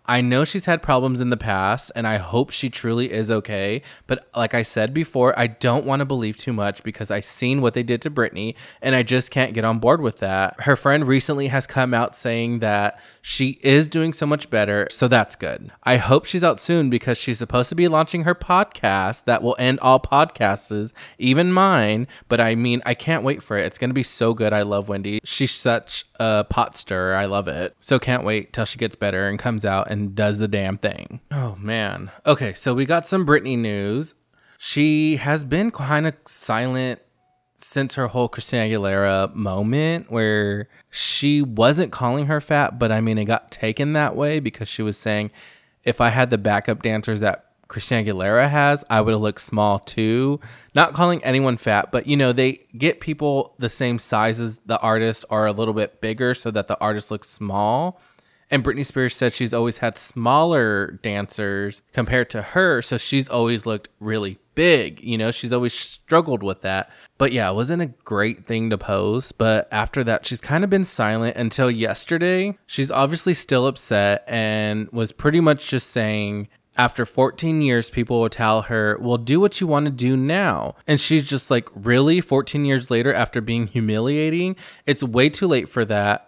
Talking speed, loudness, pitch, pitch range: 200 wpm, -20 LUFS, 120 Hz, 110-140 Hz